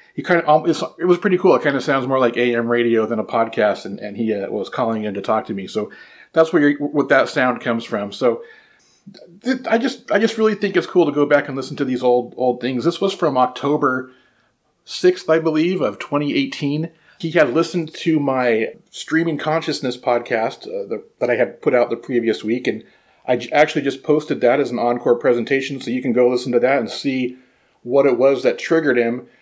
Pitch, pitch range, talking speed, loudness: 140 Hz, 125-165 Hz, 225 wpm, -19 LUFS